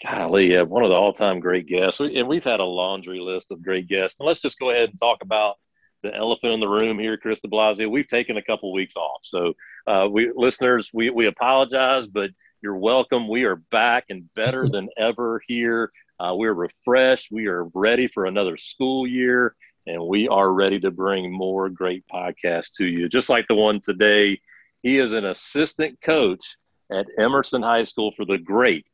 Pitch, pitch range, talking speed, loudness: 110 Hz, 95-125 Hz, 200 wpm, -21 LUFS